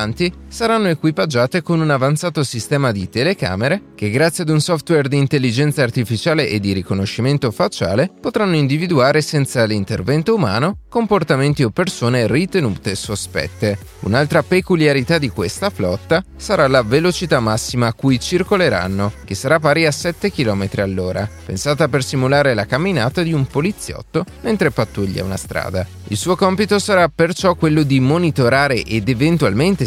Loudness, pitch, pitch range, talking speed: -17 LUFS, 140 Hz, 110-170 Hz, 145 wpm